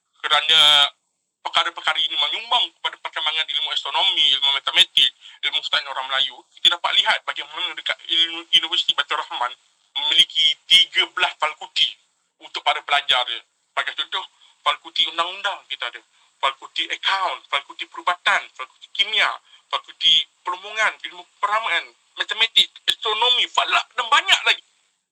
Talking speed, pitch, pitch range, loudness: 120 wpm, 170 Hz, 150-215 Hz, -19 LUFS